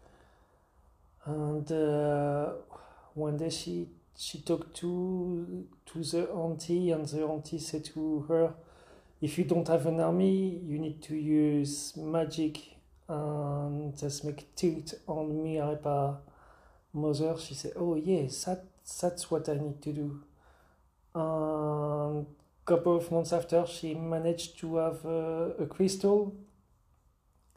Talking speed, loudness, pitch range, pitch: 130 wpm, -32 LUFS, 145-165 Hz, 155 Hz